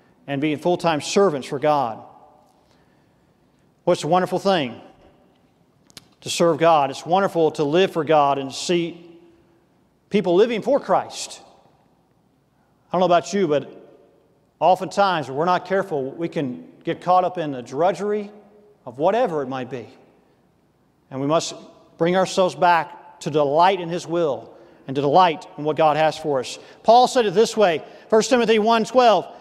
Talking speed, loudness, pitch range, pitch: 160 wpm, -20 LUFS, 155-195 Hz, 170 Hz